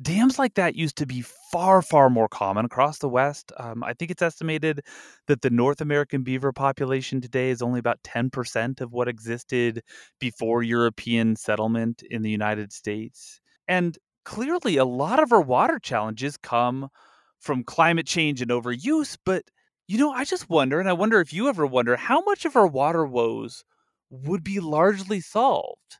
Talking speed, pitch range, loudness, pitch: 175 wpm, 120-180 Hz, -24 LUFS, 135 Hz